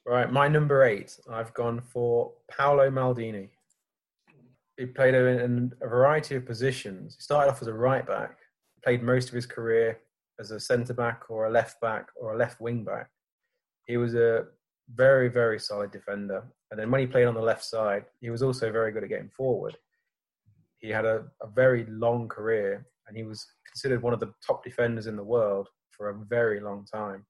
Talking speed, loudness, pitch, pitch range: 195 wpm, -27 LUFS, 120 Hz, 110-130 Hz